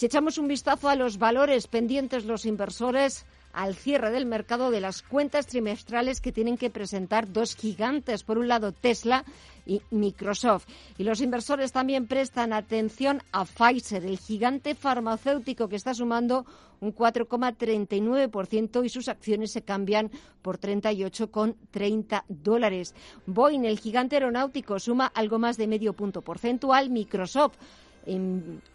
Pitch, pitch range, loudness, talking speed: 230 Hz, 210-255 Hz, -27 LUFS, 140 wpm